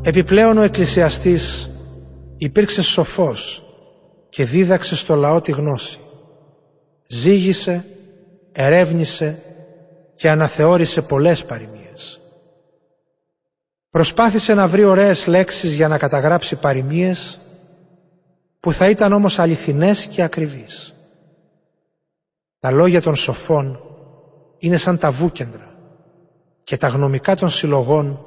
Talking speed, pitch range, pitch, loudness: 100 wpm, 150-180 Hz, 170 Hz, -16 LUFS